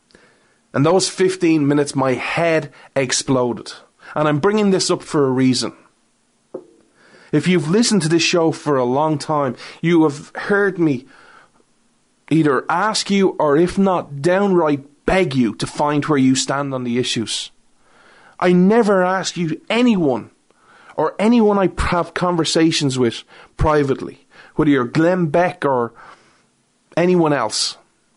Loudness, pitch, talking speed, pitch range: -17 LUFS, 160 Hz, 140 wpm, 140-180 Hz